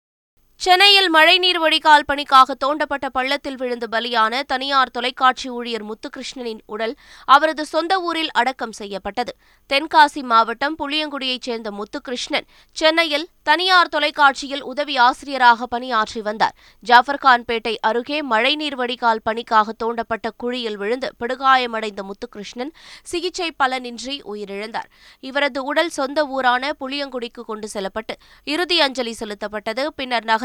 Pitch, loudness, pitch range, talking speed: 260 Hz, -18 LUFS, 230-290 Hz, 105 wpm